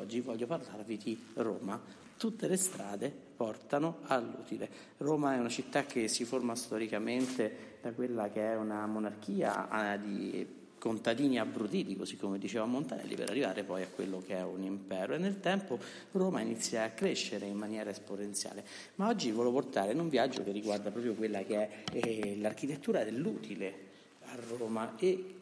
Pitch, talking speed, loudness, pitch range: 110 Hz, 165 wpm, -36 LUFS, 105-135 Hz